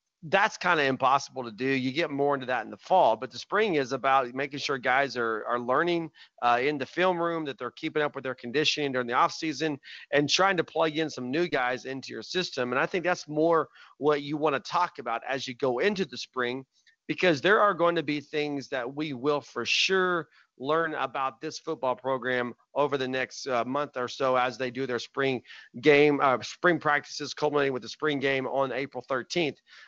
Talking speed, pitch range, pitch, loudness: 220 wpm, 130-155 Hz, 140 Hz, -27 LUFS